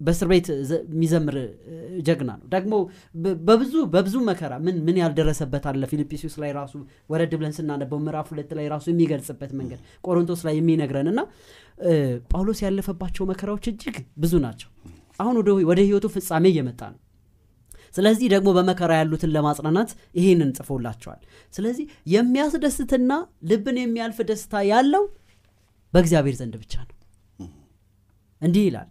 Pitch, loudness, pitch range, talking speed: 165 Hz, -23 LUFS, 140-195 Hz, 125 wpm